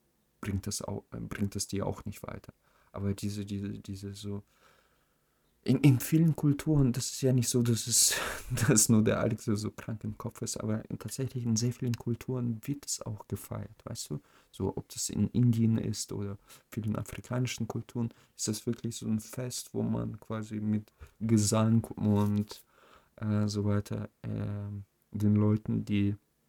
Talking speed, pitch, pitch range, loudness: 170 wpm, 110 Hz, 105-120 Hz, -31 LUFS